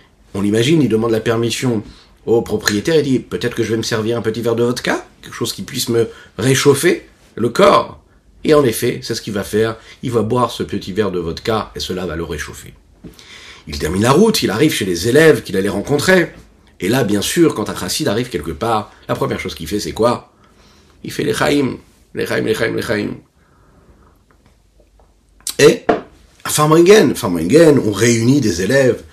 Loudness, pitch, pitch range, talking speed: -16 LUFS, 115 Hz, 100-125 Hz, 195 wpm